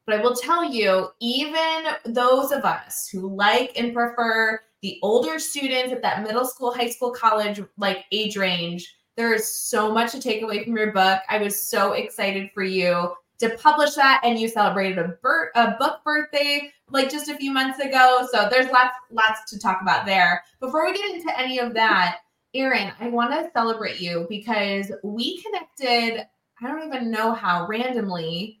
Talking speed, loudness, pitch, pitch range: 185 wpm, -22 LUFS, 230 Hz, 200-260 Hz